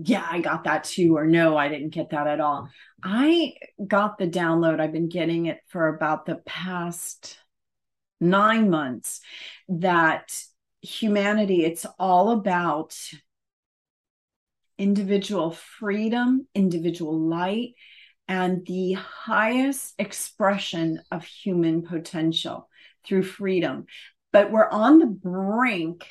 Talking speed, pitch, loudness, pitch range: 115 wpm, 180 Hz, -23 LUFS, 160-205 Hz